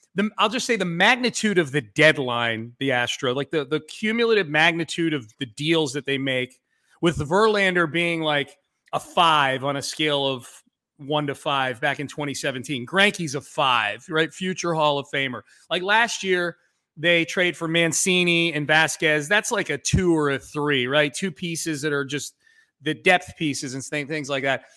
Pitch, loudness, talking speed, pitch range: 155 Hz, -22 LUFS, 180 wpm, 140-175 Hz